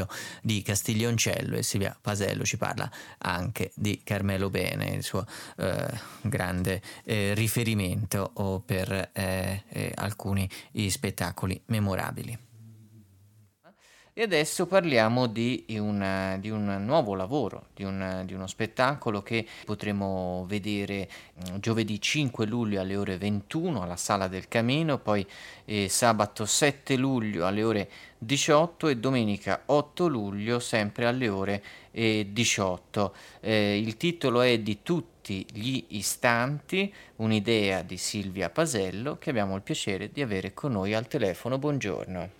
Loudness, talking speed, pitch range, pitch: -29 LUFS, 125 wpm, 95-120 Hz, 105 Hz